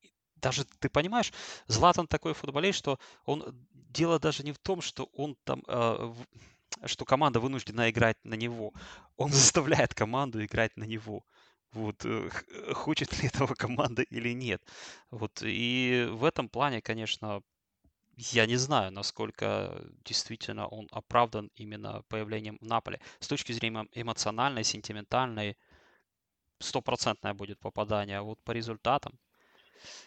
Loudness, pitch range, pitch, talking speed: -31 LUFS, 110-135 Hz, 115 Hz, 130 wpm